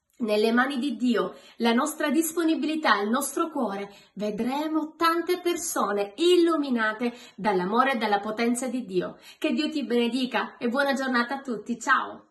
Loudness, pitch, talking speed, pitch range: -26 LUFS, 255 Hz, 145 wpm, 220-300 Hz